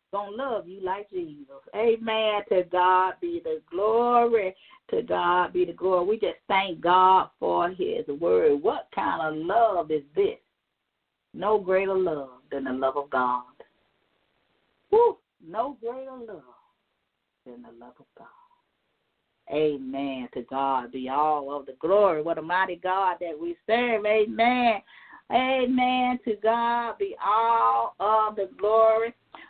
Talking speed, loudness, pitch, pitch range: 140 wpm, -25 LUFS, 215 Hz, 175-255 Hz